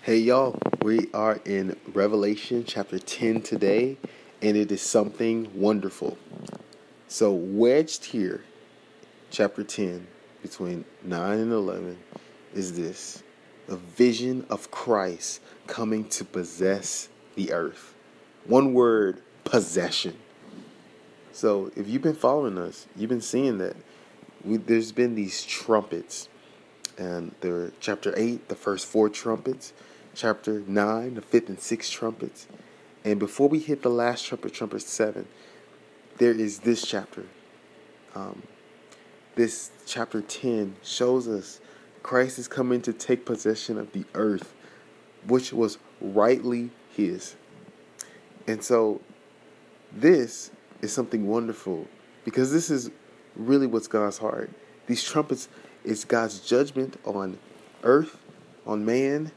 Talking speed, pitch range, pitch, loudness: 120 wpm, 105-125 Hz, 110 Hz, -26 LUFS